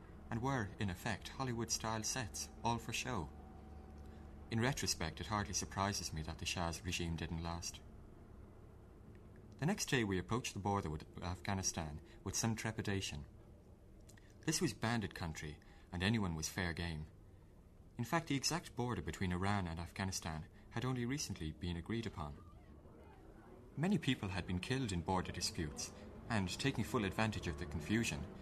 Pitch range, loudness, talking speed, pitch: 85-110 Hz, -41 LUFS, 155 wpm, 95 Hz